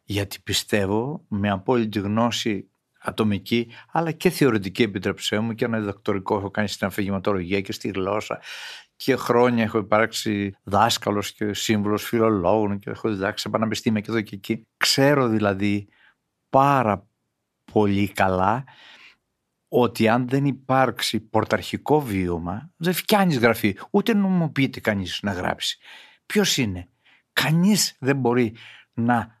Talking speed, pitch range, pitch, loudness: 130 wpm, 100-125 Hz, 110 Hz, -23 LUFS